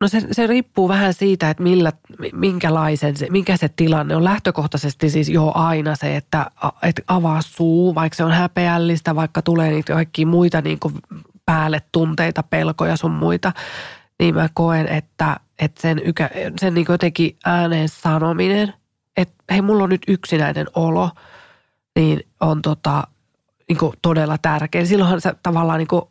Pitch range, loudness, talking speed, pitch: 155-180 Hz, -18 LUFS, 150 wpm, 165 Hz